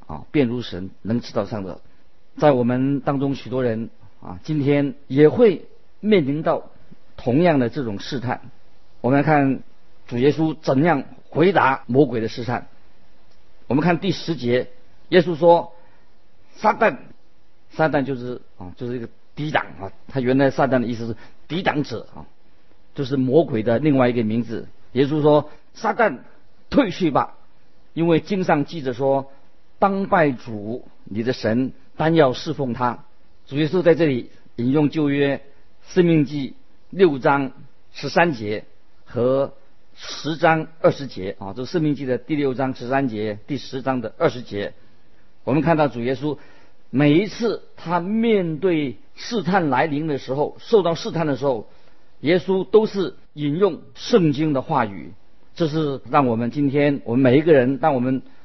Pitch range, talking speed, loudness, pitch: 120-155 Hz, 225 characters per minute, -21 LUFS, 140 Hz